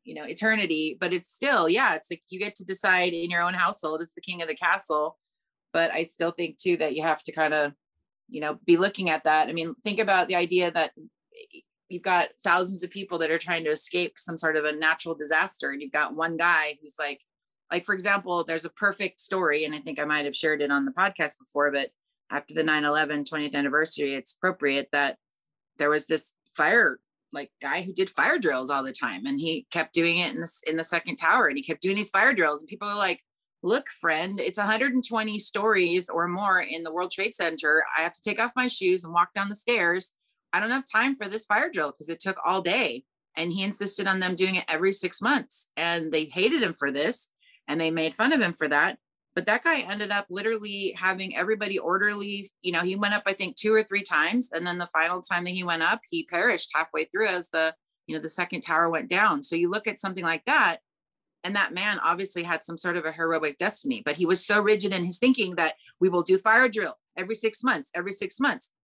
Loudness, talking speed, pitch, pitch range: -25 LUFS, 240 wpm, 175 Hz, 160-200 Hz